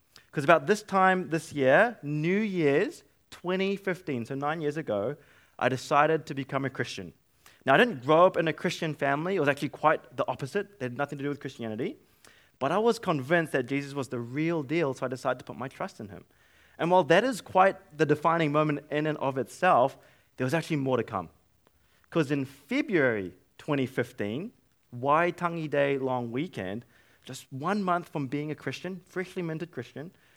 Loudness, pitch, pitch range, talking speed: -28 LUFS, 150 Hz, 130-175 Hz, 190 wpm